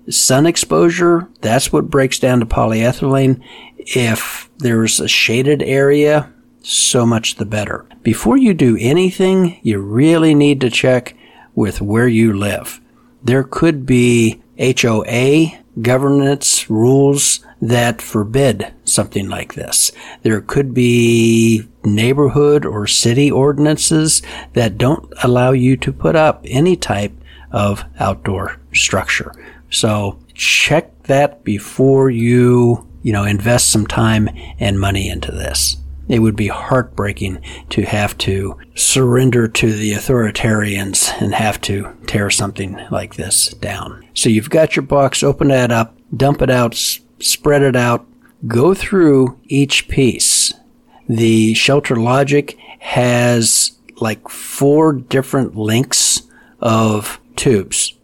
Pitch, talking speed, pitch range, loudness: 120 Hz, 125 wpm, 110-140 Hz, -14 LUFS